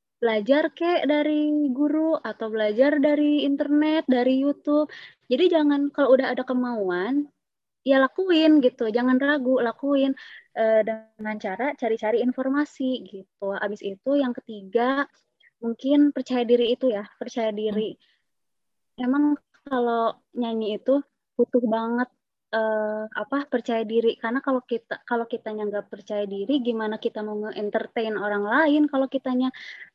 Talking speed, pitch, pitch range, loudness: 130 wpm, 250 Hz, 220-280 Hz, -24 LUFS